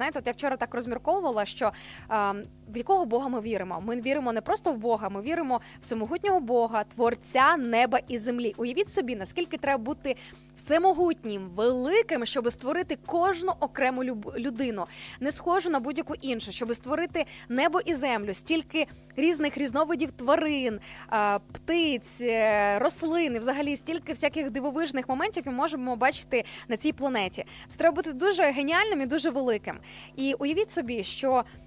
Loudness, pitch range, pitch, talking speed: -28 LUFS, 235-320 Hz, 275 Hz, 150 wpm